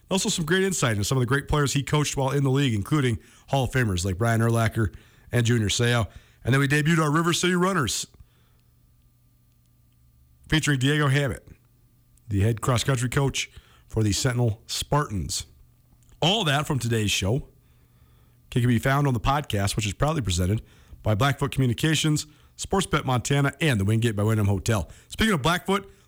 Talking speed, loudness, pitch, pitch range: 170 wpm, -24 LUFS, 125 Hz, 105-145 Hz